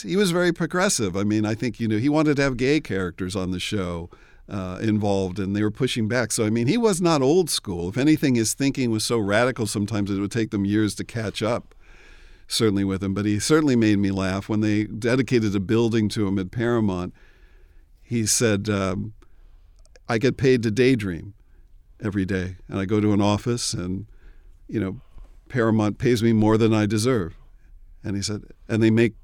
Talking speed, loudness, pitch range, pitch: 205 wpm, -23 LUFS, 95-120 Hz, 105 Hz